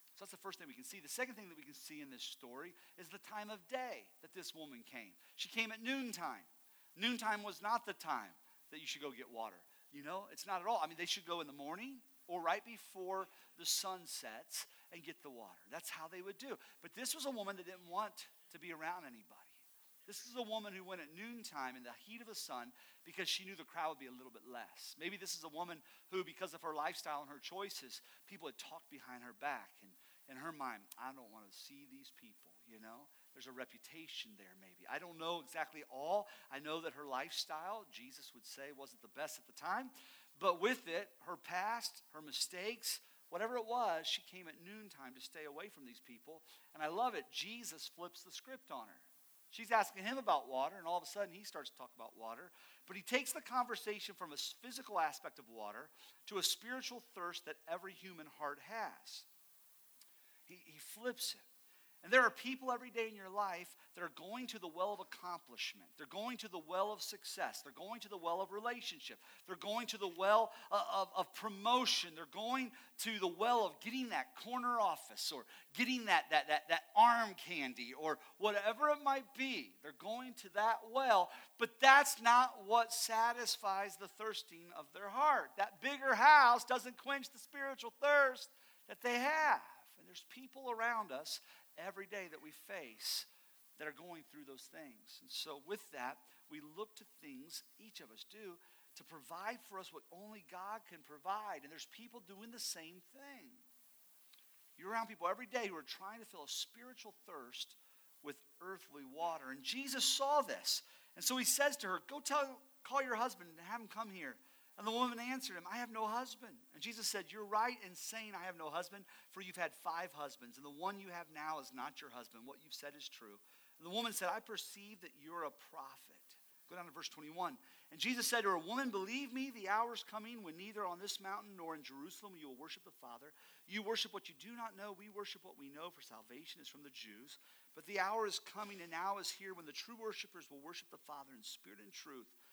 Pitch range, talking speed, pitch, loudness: 170-245 Hz, 220 wpm, 205 Hz, -40 LUFS